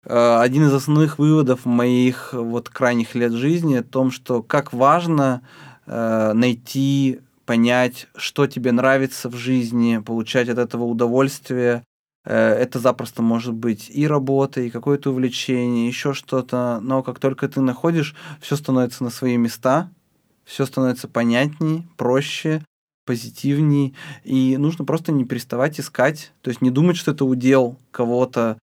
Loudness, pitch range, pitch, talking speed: -20 LUFS, 120-140 Hz, 130 Hz, 135 wpm